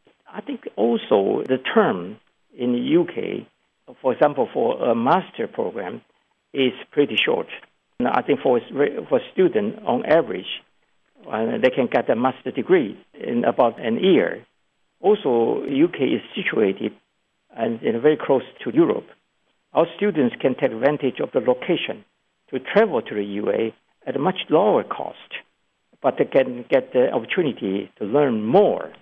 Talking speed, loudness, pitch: 145 wpm, -21 LUFS, 145 Hz